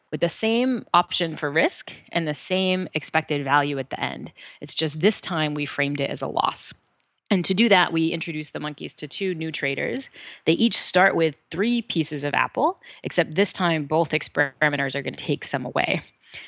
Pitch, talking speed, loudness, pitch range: 160 Hz, 195 wpm, -23 LUFS, 150-185 Hz